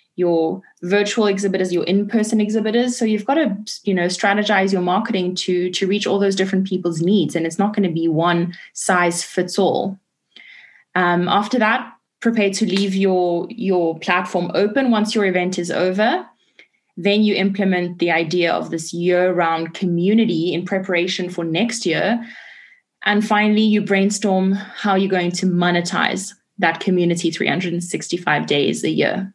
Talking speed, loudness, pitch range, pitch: 155 wpm, -19 LUFS, 175-205 Hz, 190 Hz